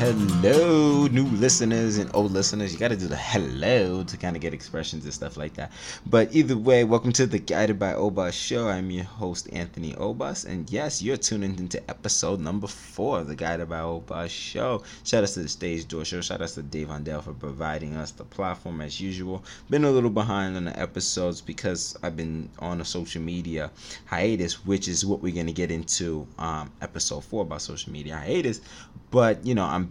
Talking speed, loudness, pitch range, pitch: 205 wpm, -26 LUFS, 80-105 Hz, 90 Hz